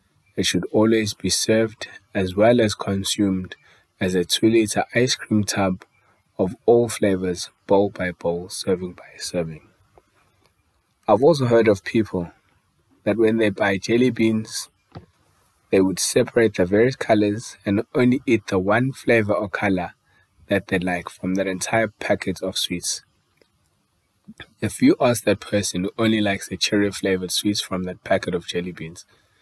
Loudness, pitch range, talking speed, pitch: -21 LUFS, 95-110 Hz, 155 wpm, 105 Hz